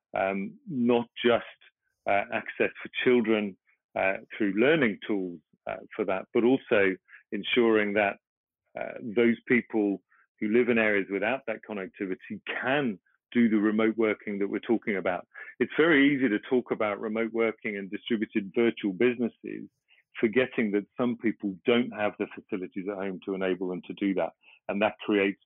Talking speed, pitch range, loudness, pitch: 160 wpm, 100-120 Hz, -28 LUFS, 110 Hz